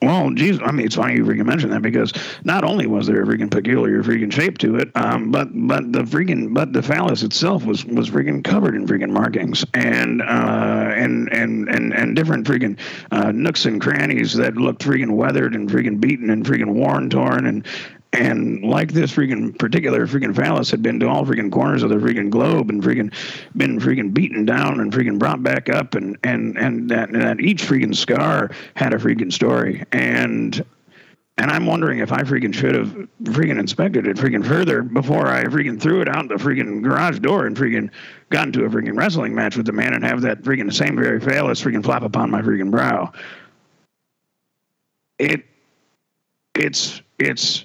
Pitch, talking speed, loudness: 65 Hz, 195 wpm, -18 LUFS